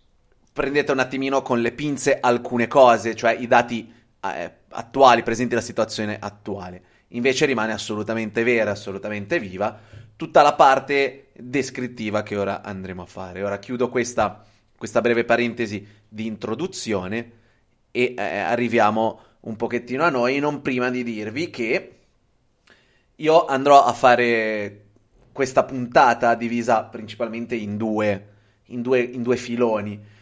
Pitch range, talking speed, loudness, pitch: 105-125 Hz, 135 wpm, -21 LUFS, 115 Hz